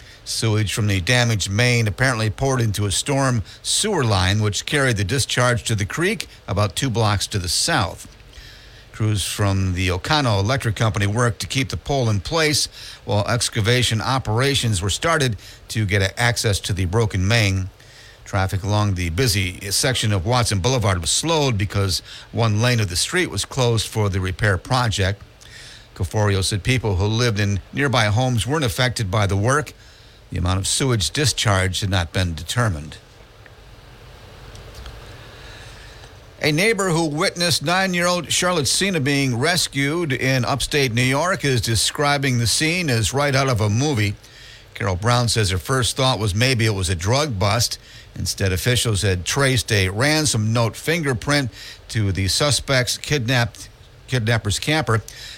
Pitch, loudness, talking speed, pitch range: 115 Hz, -20 LUFS, 160 wpm, 100-130 Hz